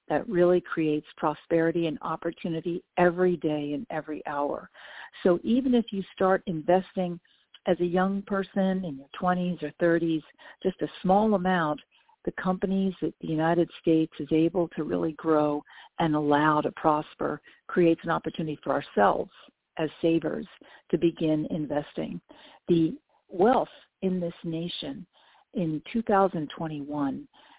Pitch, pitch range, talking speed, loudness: 170 Hz, 155-185 Hz, 135 wpm, -27 LUFS